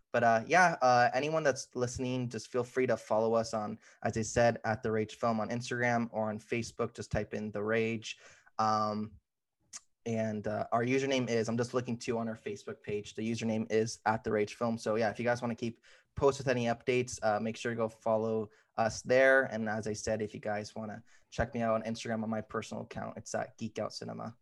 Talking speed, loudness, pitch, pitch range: 235 wpm, -33 LUFS, 115 Hz, 110-120 Hz